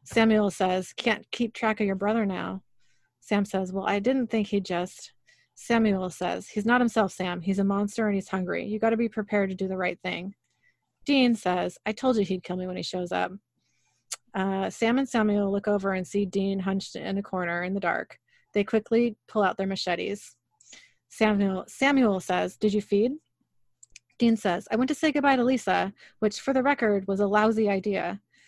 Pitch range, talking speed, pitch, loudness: 190-225 Hz, 200 wpm, 205 Hz, -26 LUFS